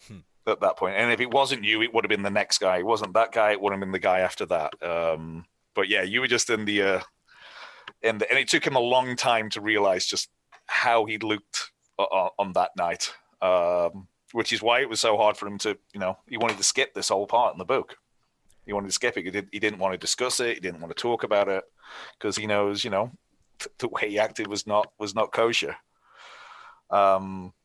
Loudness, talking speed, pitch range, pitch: -25 LUFS, 245 wpm, 95-115 Hz, 105 Hz